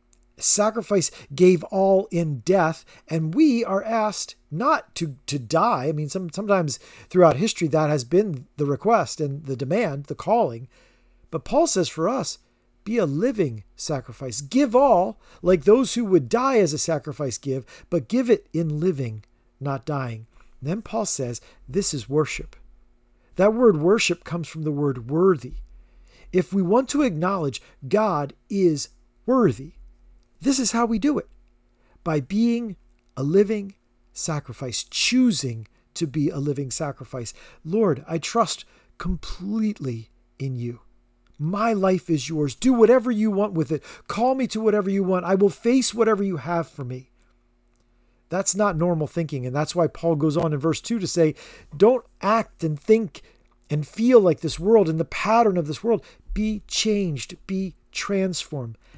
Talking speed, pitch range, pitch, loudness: 165 wpm, 135-205 Hz, 165 Hz, -22 LUFS